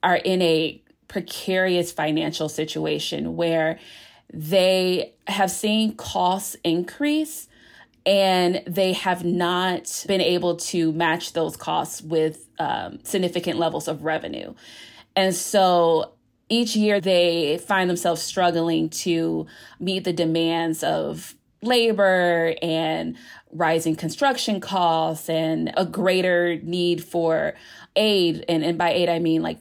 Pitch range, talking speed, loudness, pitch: 160-190 Hz, 120 wpm, -22 LUFS, 175 Hz